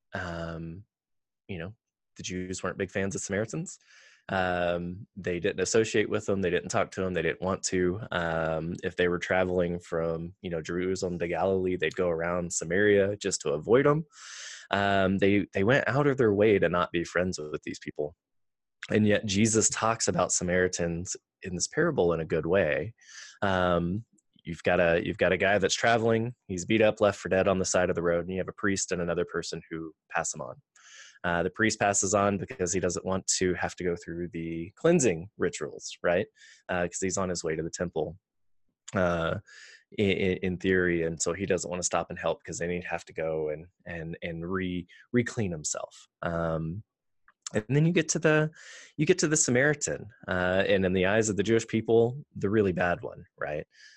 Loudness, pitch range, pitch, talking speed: -28 LUFS, 85-105 Hz, 95 Hz, 205 wpm